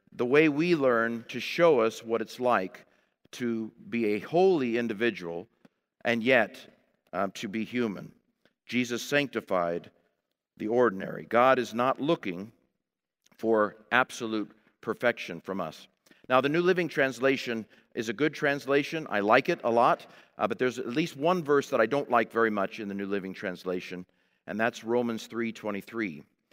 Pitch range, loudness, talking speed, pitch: 110-135 Hz, -28 LUFS, 160 wpm, 120 Hz